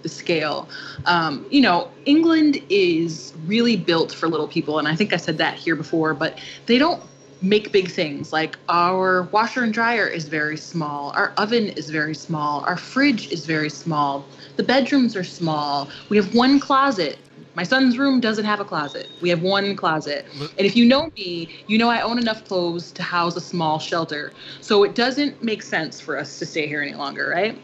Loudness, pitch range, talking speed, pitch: -21 LUFS, 155-230 Hz, 200 wpm, 175 Hz